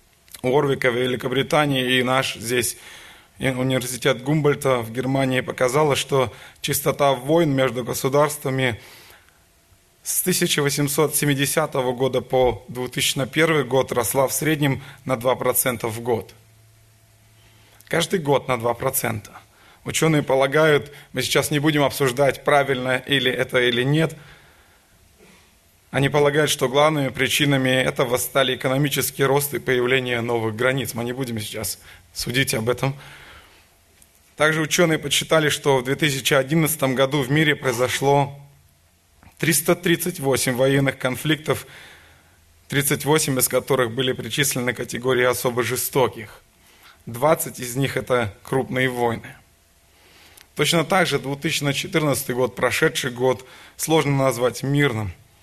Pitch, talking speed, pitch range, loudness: 130 Hz, 115 wpm, 120-145 Hz, -21 LUFS